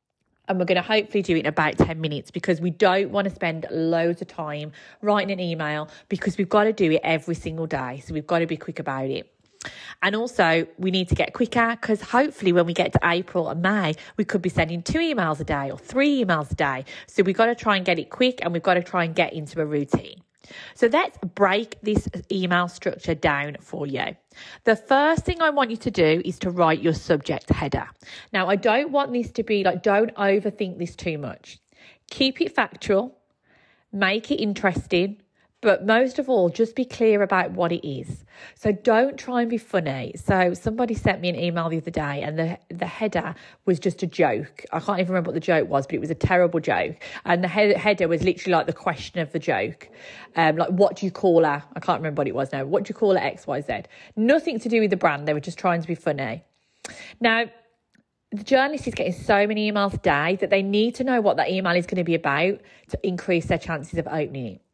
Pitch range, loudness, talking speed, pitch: 165-210 Hz, -23 LUFS, 235 wpm, 180 Hz